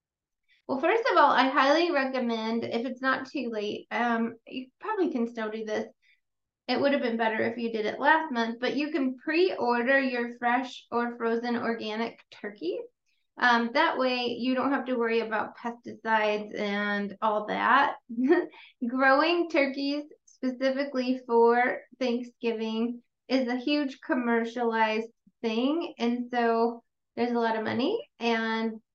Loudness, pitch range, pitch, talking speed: -27 LUFS, 230-275 Hz, 245 Hz, 145 wpm